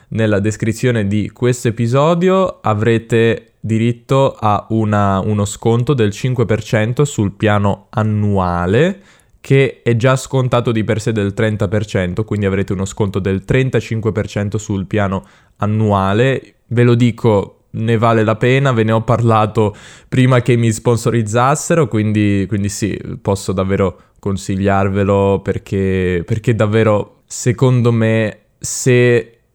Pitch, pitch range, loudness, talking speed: 110 Hz, 100-120 Hz, -15 LUFS, 125 wpm